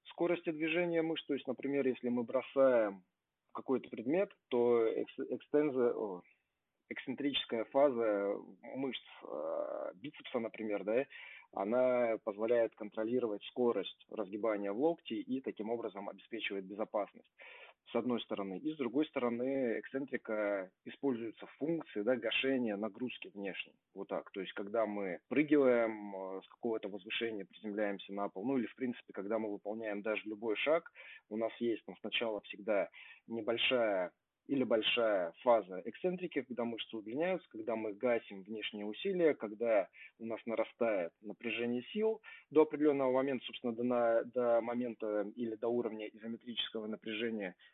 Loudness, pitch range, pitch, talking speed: -37 LUFS, 110-135 Hz, 115 Hz, 140 wpm